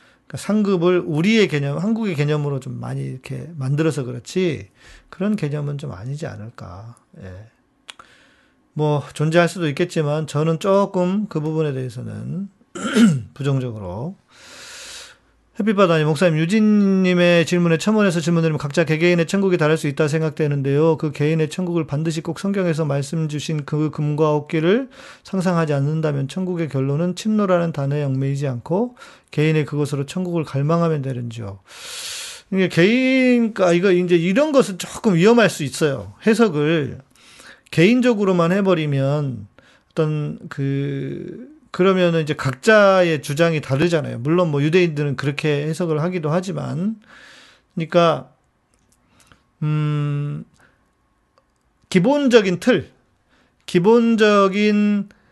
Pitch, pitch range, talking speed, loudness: 160 Hz, 145-190 Hz, 295 characters per minute, -19 LUFS